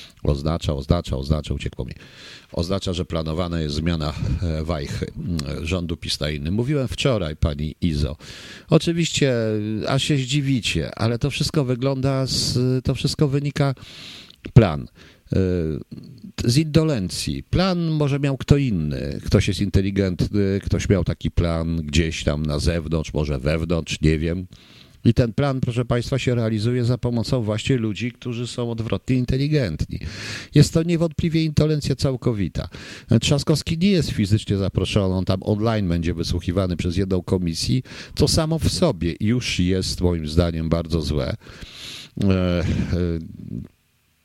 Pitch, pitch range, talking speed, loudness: 100 Hz, 85-130 Hz, 130 wpm, -22 LUFS